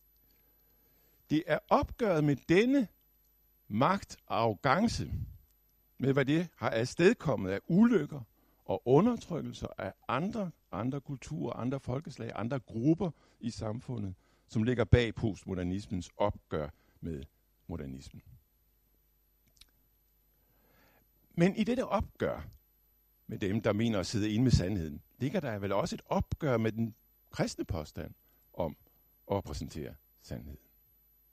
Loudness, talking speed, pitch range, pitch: -32 LUFS, 115 wpm, 105-150 Hz, 120 Hz